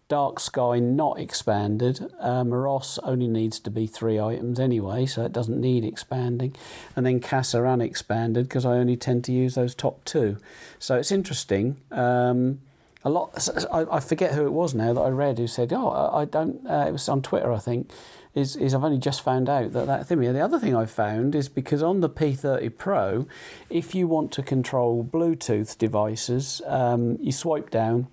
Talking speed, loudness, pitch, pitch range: 195 wpm, -25 LUFS, 125 Hz, 120-140 Hz